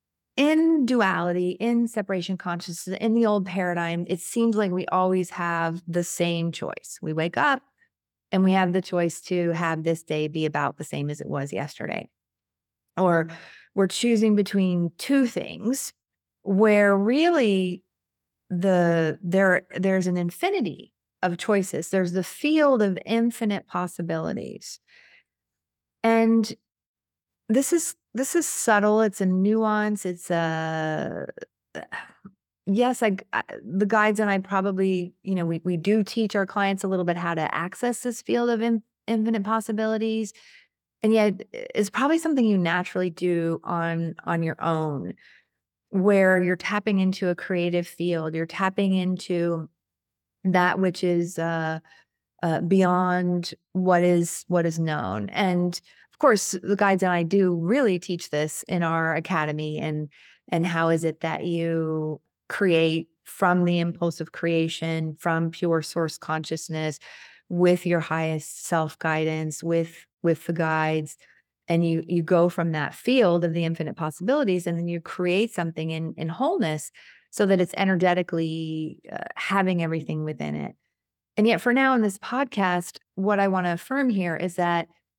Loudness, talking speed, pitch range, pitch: -24 LUFS, 150 wpm, 165-205 Hz, 180 Hz